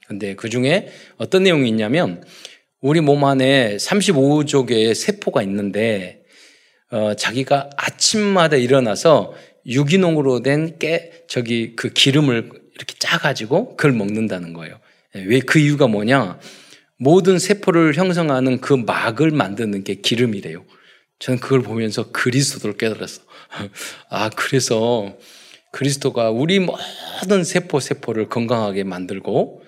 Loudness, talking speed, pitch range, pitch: -18 LUFS, 275 characters per minute, 115-155 Hz, 135 Hz